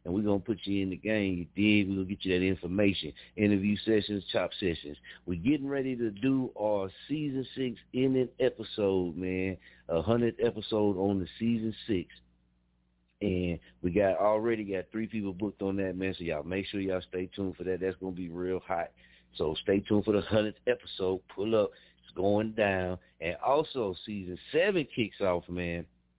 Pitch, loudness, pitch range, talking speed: 95 Hz, -31 LUFS, 90-105 Hz, 190 wpm